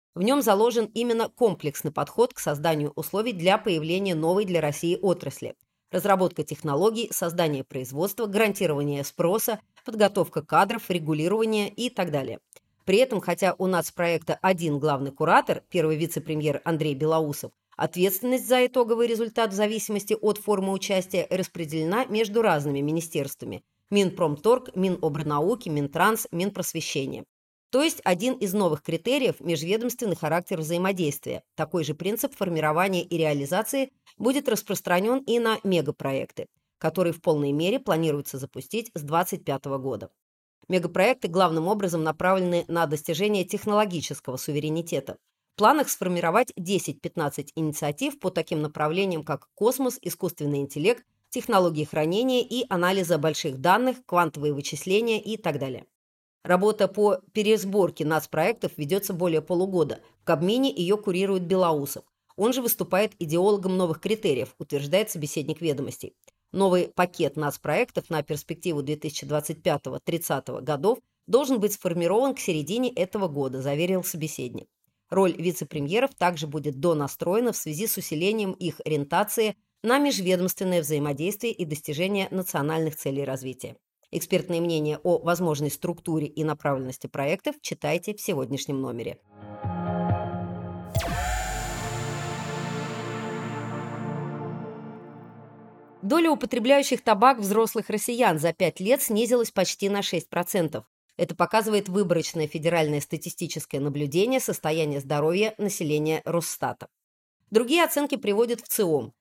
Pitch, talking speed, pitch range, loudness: 175 Hz, 115 wpm, 155-210 Hz, -26 LUFS